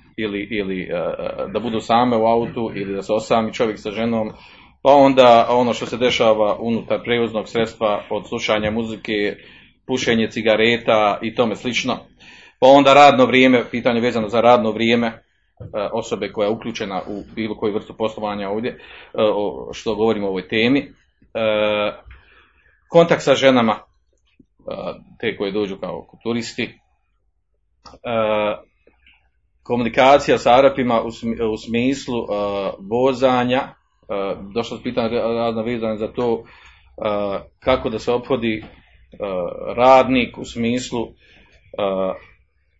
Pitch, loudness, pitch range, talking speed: 115 Hz, -18 LUFS, 105-120 Hz, 135 wpm